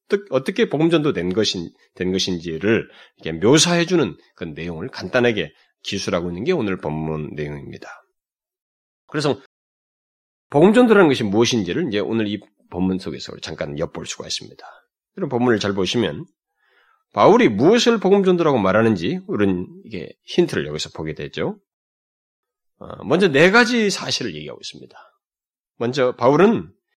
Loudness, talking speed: -19 LUFS, 320 characters per minute